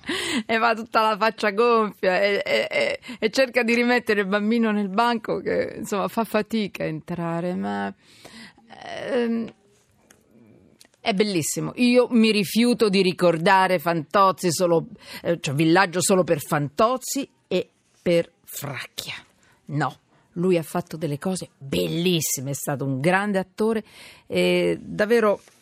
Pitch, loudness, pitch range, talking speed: 200 Hz, -22 LUFS, 170-230 Hz, 135 wpm